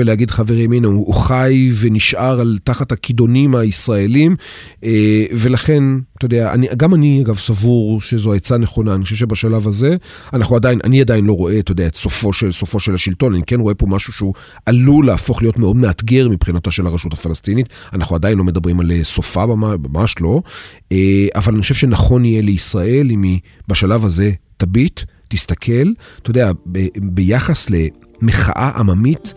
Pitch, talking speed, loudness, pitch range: 110 Hz, 160 wpm, -14 LUFS, 95-125 Hz